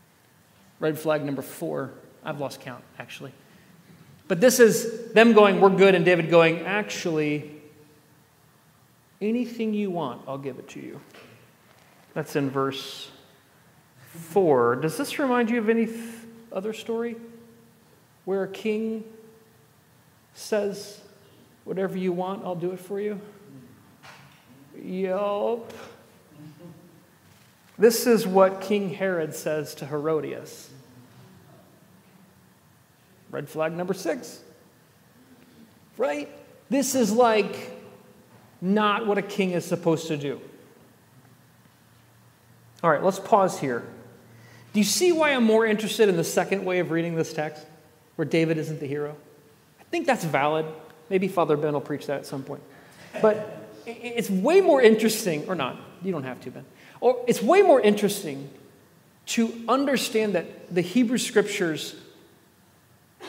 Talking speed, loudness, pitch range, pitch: 130 wpm, -24 LUFS, 150-215 Hz, 185 Hz